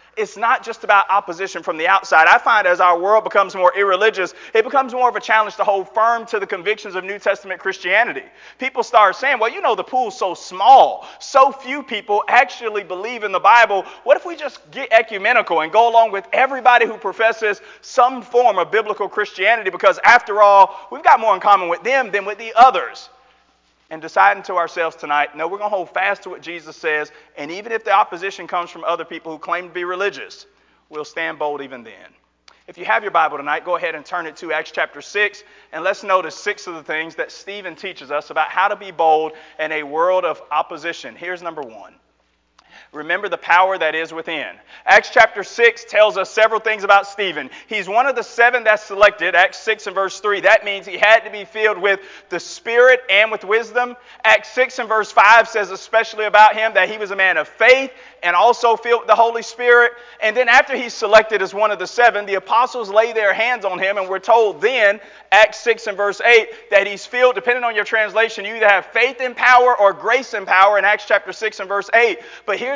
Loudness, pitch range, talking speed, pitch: -16 LUFS, 190-235 Hz, 225 wpm, 210 Hz